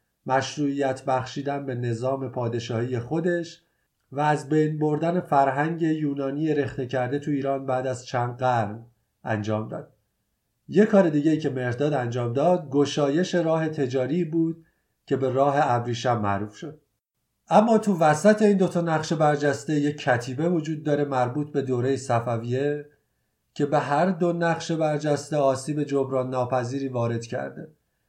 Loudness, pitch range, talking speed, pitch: -24 LUFS, 130-155 Hz, 140 wpm, 140 Hz